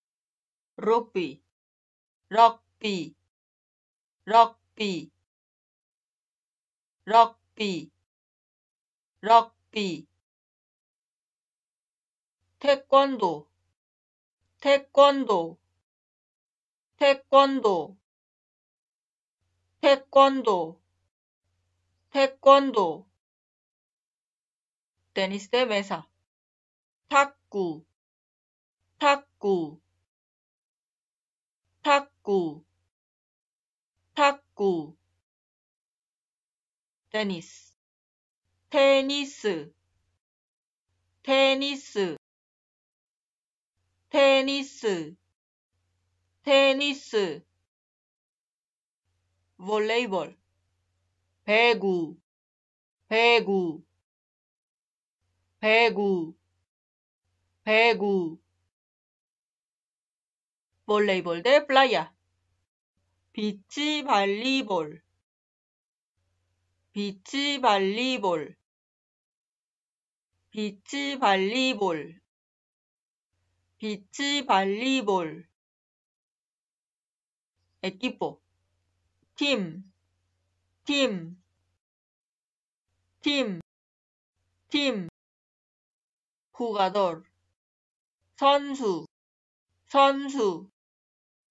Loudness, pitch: -24 LUFS, 165 Hz